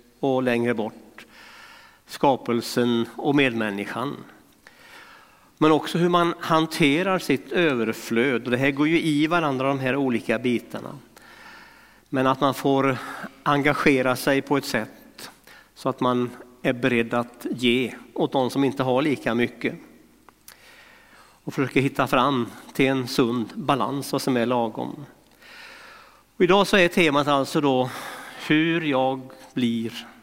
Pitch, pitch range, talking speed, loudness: 135 Hz, 120-155 Hz, 135 wpm, -23 LUFS